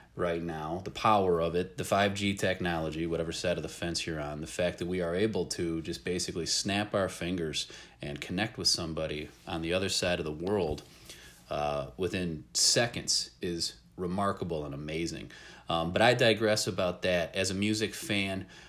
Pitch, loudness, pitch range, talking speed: 90 Hz, -31 LUFS, 80-100 Hz, 180 wpm